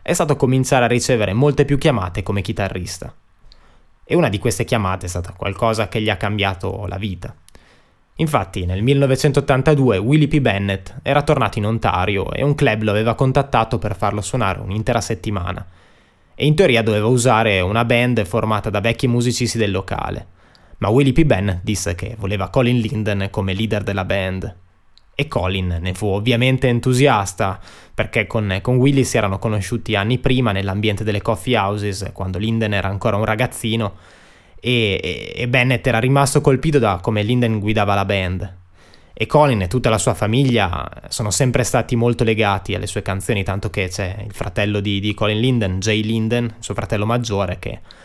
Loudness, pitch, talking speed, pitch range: -18 LUFS, 110 Hz, 175 wpm, 100-125 Hz